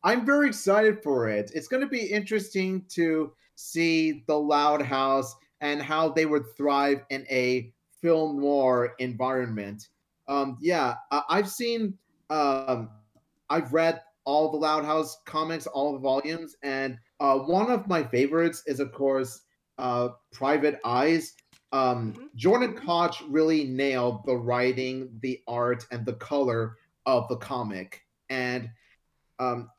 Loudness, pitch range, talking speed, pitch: -27 LUFS, 125-160 Hz, 140 wpm, 140 Hz